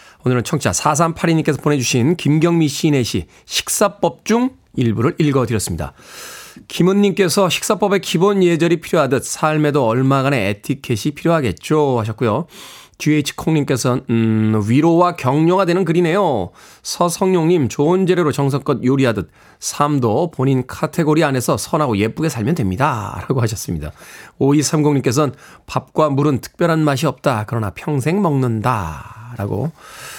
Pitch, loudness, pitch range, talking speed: 145 Hz, -17 LUFS, 120-165 Hz, 320 characters per minute